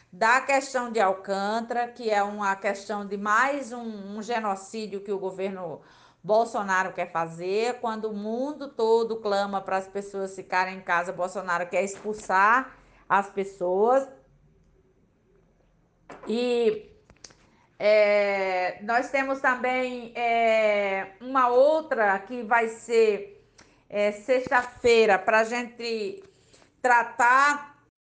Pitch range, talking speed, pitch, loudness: 195-245 Hz, 110 wpm, 220 Hz, -25 LUFS